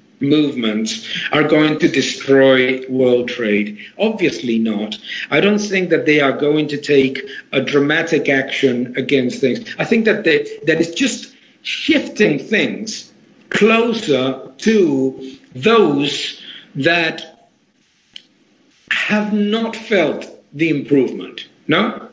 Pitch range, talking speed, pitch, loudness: 130-210 Hz, 115 wpm, 150 Hz, -16 LUFS